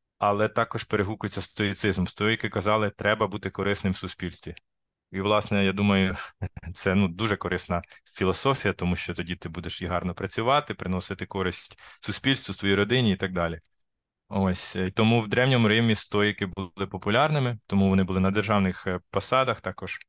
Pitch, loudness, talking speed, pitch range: 100 Hz, -26 LUFS, 155 wpm, 95-105 Hz